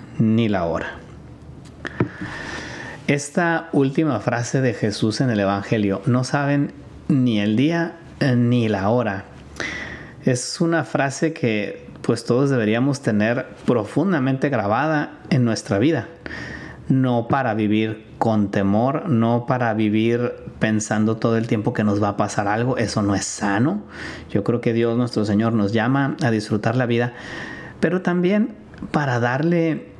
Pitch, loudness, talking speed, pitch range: 120 Hz, -21 LUFS, 140 wpm, 110-140 Hz